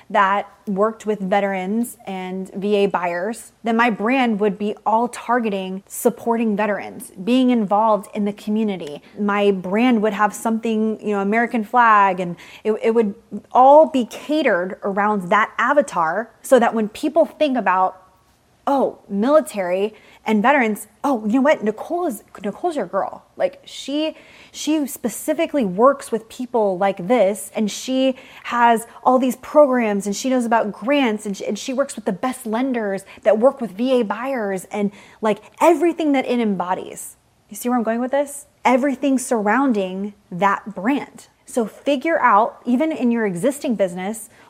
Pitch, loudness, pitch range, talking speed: 225 Hz, -19 LUFS, 205-260 Hz, 160 wpm